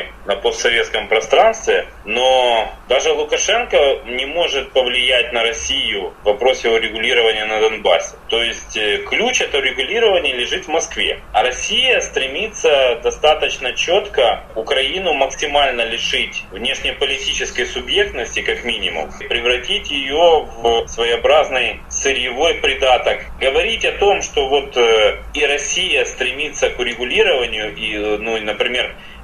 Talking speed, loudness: 115 wpm, -16 LUFS